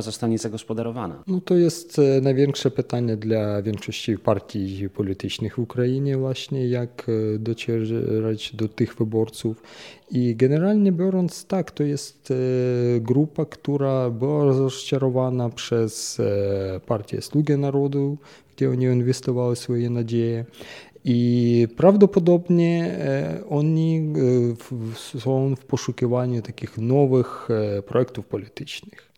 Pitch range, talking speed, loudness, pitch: 115-140 Hz, 95 wpm, -23 LUFS, 125 Hz